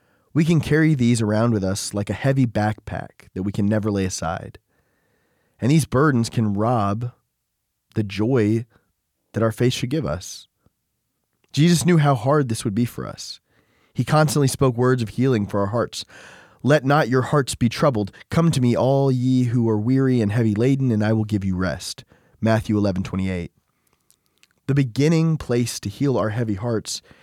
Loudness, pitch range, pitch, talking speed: -21 LUFS, 105-135 Hz, 120 Hz, 185 wpm